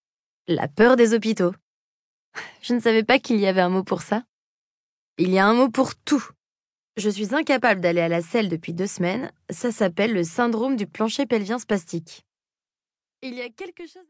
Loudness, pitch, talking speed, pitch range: -22 LUFS, 220 Hz, 190 wpm, 185-245 Hz